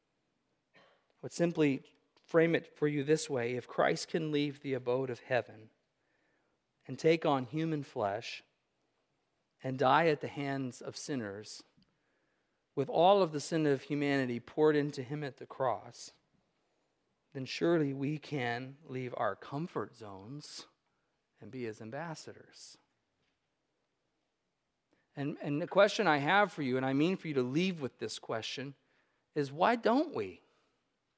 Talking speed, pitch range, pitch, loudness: 145 wpm, 130-160 Hz, 145 Hz, -33 LUFS